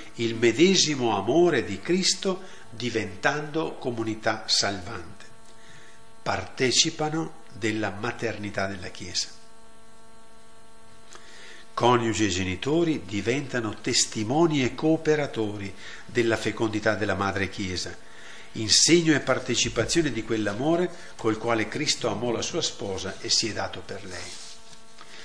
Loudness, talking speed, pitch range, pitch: -25 LUFS, 100 wpm, 110-145 Hz, 115 Hz